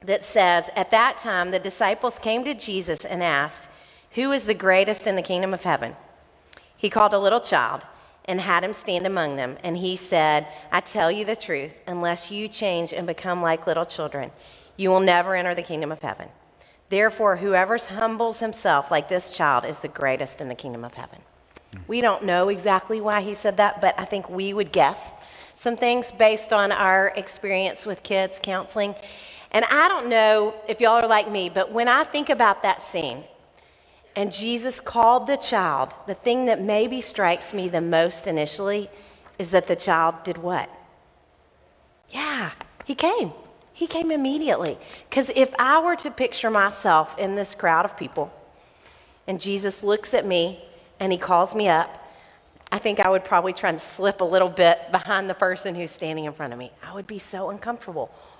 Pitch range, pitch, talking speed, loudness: 175-220 Hz, 195 Hz, 190 wpm, -22 LUFS